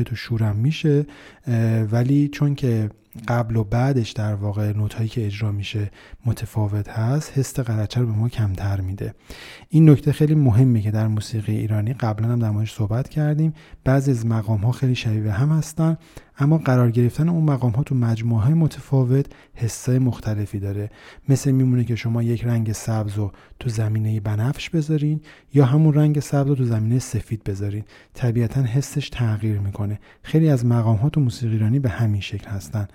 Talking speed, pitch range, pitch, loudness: 170 wpm, 110-135 Hz, 115 Hz, -21 LUFS